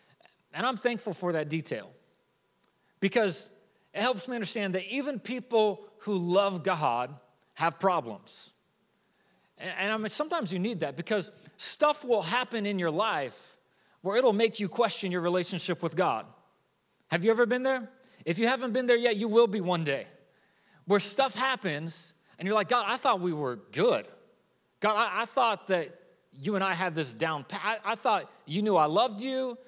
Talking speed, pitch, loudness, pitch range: 185 wpm, 205 Hz, -29 LUFS, 180-235 Hz